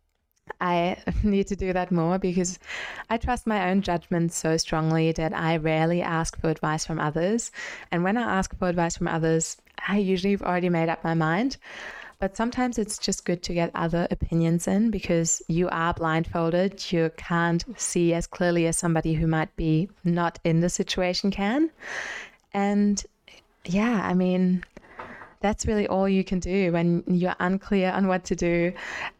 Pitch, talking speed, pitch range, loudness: 180 Hz, 175 wpm, 165-195 Hz, -25 LUFS